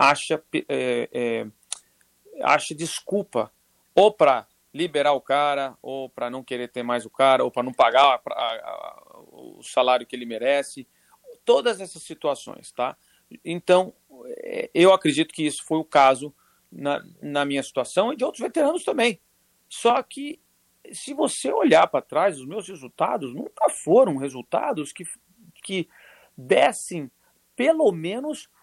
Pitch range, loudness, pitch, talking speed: 135-225 Hz, -23 LUFS, 160 Hz, 145 wpm